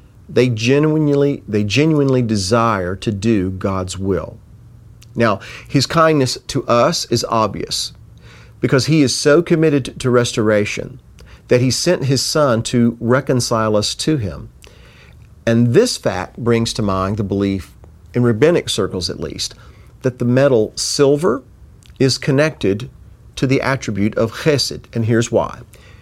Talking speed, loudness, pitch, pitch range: 140 wpm, -16 LUFS, 120 Hz, 110-135 Hz